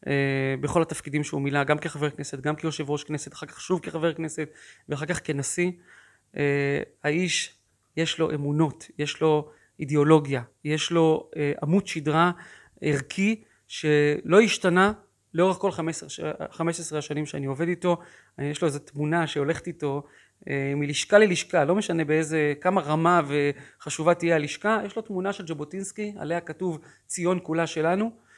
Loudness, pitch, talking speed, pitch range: -26 LUFS, 160 Hz, 150 wpm, 150-175 Hz